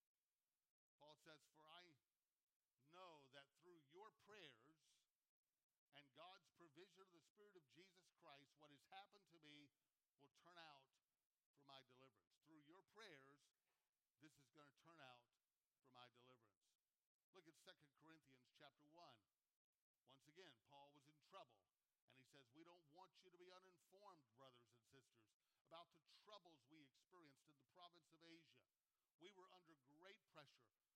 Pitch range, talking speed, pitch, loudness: 135-170 Hz, 155 wpm, 150 Hz, -68 LUFS